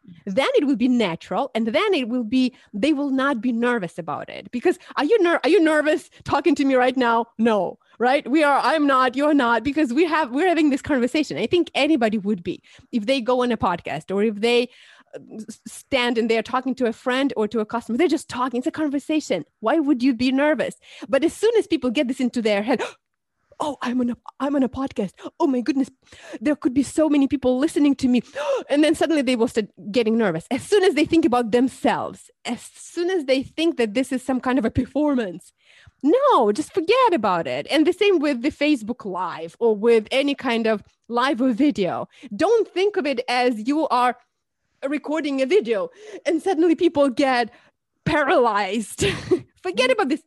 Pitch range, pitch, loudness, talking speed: 240-310 Hz, 270 Hz, -21 LUFS, 210 wpm